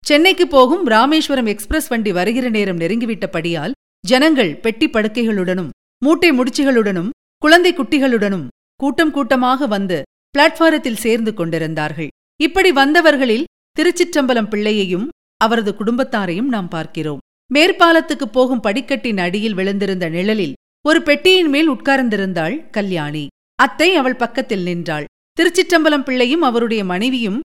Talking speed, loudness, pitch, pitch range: 105 wpm, -15 LUFS, 245 Hz, 200-295 Hz